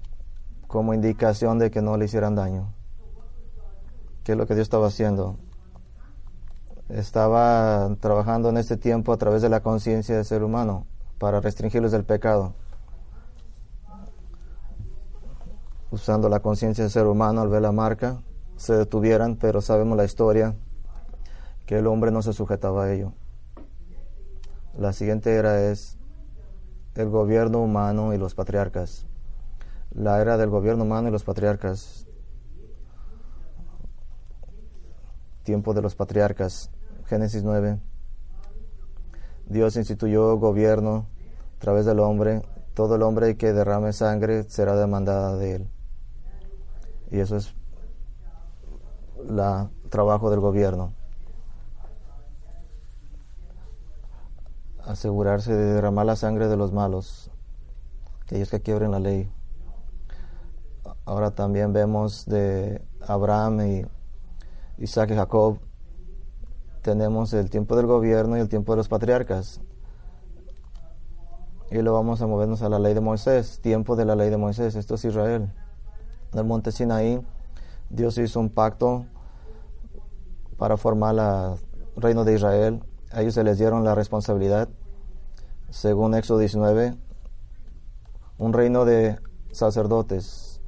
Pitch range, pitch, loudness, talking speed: 95-110 Hz, 105 Hz, -23 LUFS, 120 wpm